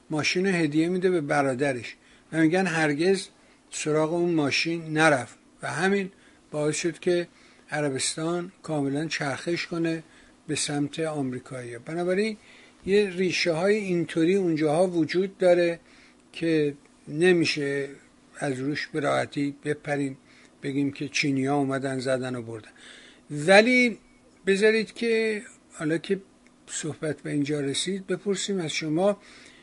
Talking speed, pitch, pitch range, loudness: 115 wpm, 160 Hz, 145-185 Hz, -26 LUFS